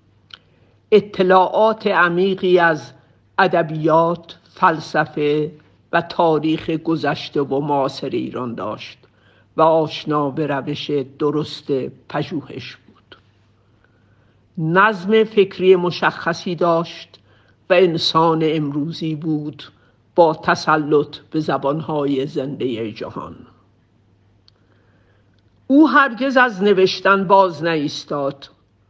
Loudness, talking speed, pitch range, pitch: -18 LUFS, 80 wpm, 125-175 Hz, 150 Hz